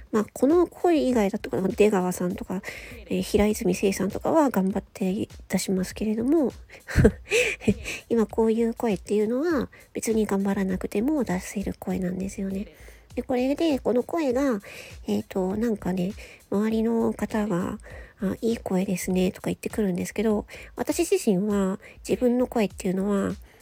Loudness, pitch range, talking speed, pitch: -25 LUFS, 190-235 Hz, 305 characters per minute, 210 Hz